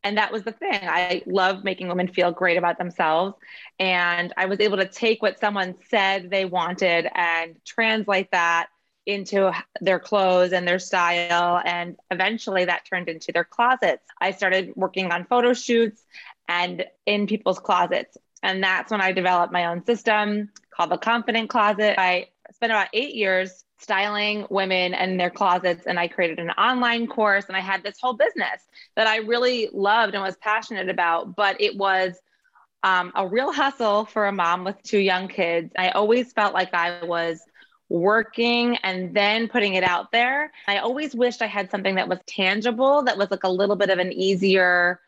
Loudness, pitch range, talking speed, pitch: -22 LUFS, 180-215 Hz, 180 wpm, 195 Hz